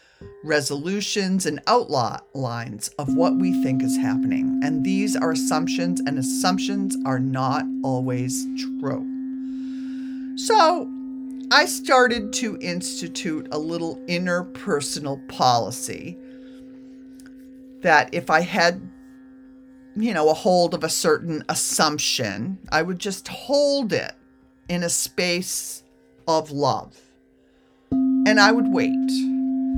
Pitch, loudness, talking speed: 185 Hz, -22 LUFS, 110 wpm